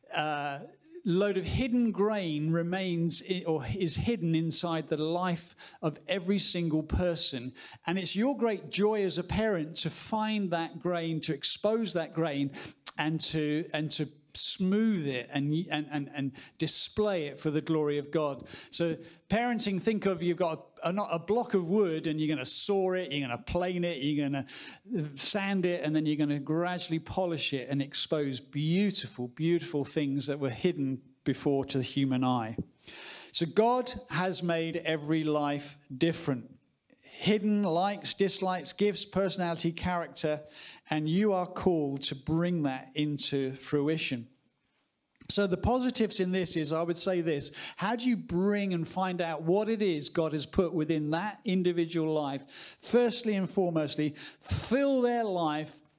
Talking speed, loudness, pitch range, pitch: 165 wpm, -31 LUFS, 150-190 Hz, 165 Hz